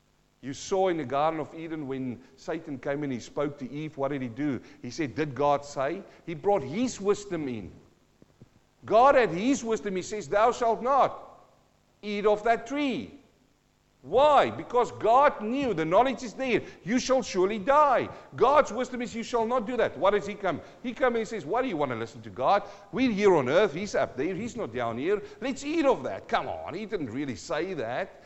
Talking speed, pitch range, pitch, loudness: 215 wpm, 150-245 Hz, 205 Hz, -27 LUFS